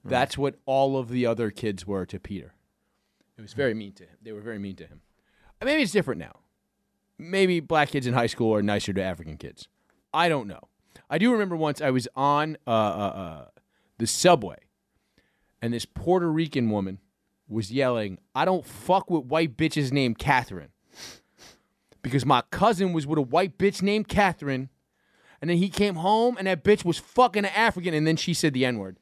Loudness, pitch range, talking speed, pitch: -25 LUFS, 110-180 Hz, 200 wpm, 140 Hz